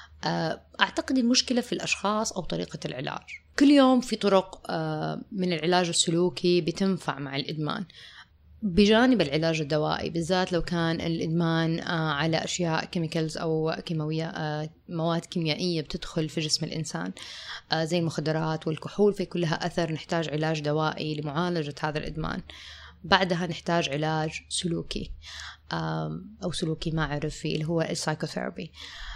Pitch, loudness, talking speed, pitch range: 165 Hz, -27 LUFS, 115 wpm, 155-180 Hz